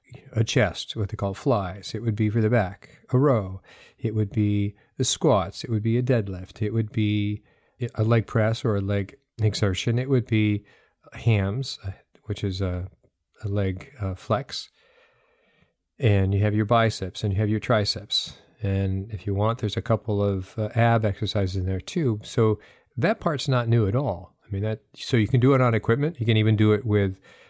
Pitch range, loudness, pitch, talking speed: 100-115 Hz, -25 LUFS, 110 Hz, 200 wpm